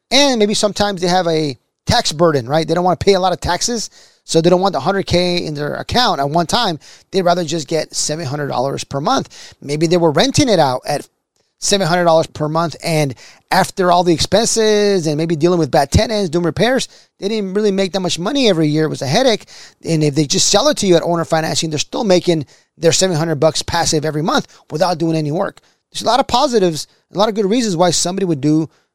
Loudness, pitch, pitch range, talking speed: -15 LUFS, 175 Hz, 160-195 Hz, 240 wpm